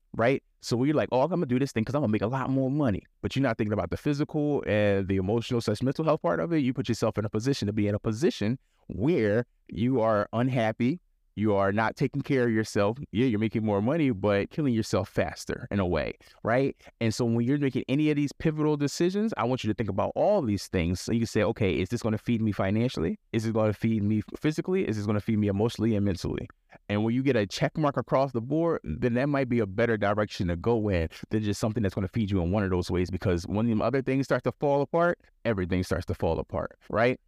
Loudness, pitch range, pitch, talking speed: -27 LUFS, 105-135 Hz, 115 Hz, 265 wpm